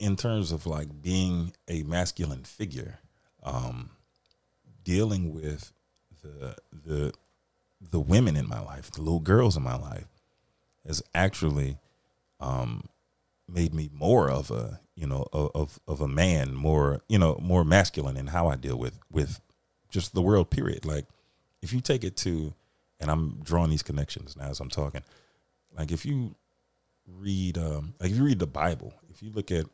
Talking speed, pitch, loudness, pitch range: 170 wpm, 80 Hz, -29 LUFS, 70-90 Hz